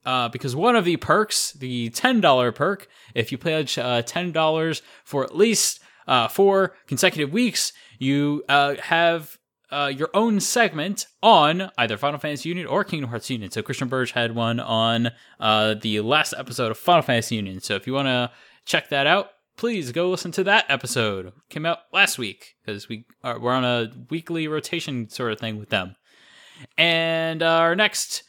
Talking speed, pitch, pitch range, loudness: 190 wpm, 145 Hz, 120-170 Hz, -22 LUFS